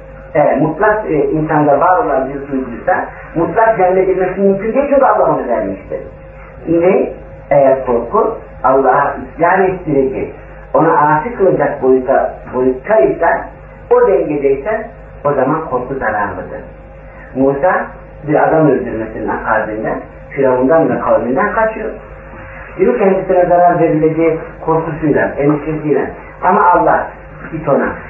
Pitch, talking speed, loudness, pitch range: 160 Hz, 115 wpm, -13 LUFS, 135-185 Hz